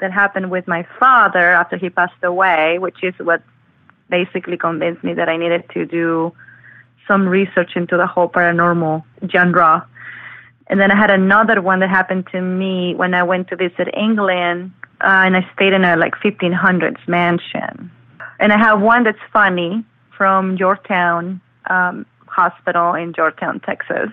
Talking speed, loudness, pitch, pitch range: 160 wpm, -15 LUFS, 180 Hz, 175-190 Hz